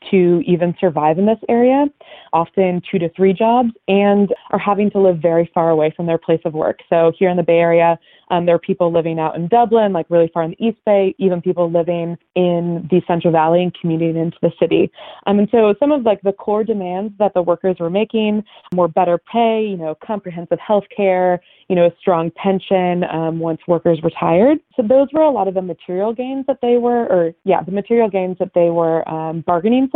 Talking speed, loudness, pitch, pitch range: 220 wpm, -16 LUFS, 180 Hz, 170-210 Hz